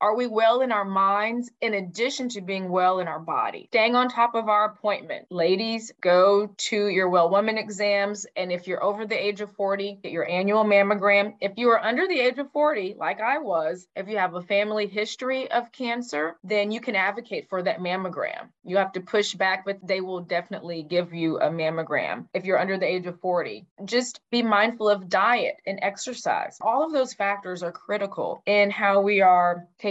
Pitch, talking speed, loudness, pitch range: 200 Hz, 205 wpm, -24 LUFS, 185-225 Hz